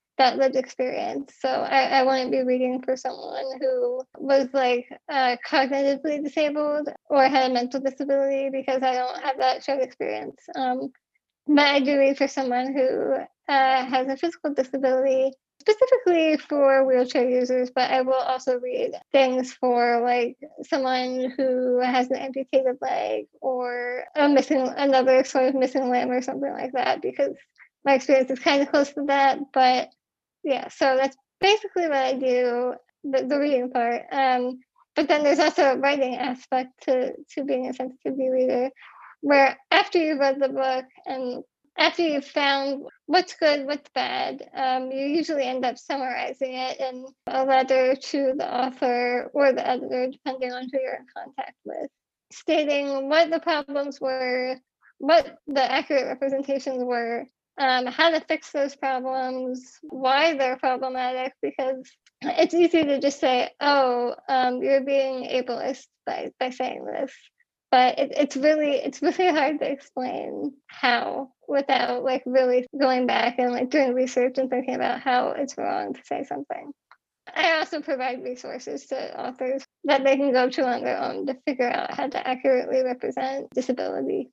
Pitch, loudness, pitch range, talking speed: 265 Hz, -24 LUFS, 255-285 Hz, 160 wpm